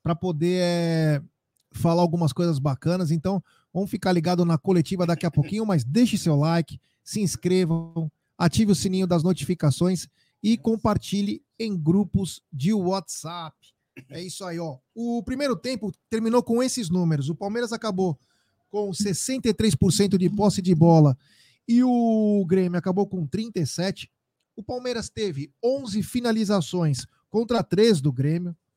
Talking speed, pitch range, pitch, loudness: 140 wpm, 165-210 Hz, 180 Hz, -24 LUFS